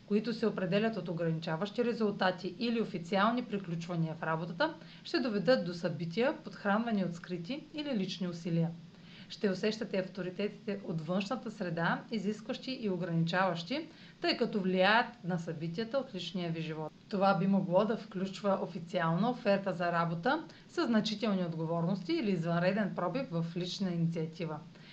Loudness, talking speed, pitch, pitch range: -34 LUFS, 135 wpm, 190 Hz, 175-220 Hz